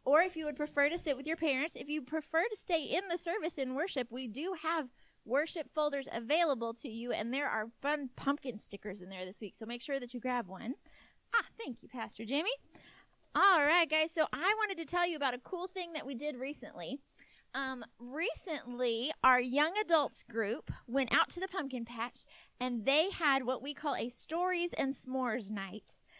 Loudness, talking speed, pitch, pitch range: -35 LUFS, 205 wpm, 280 Hz, 245-320 Hz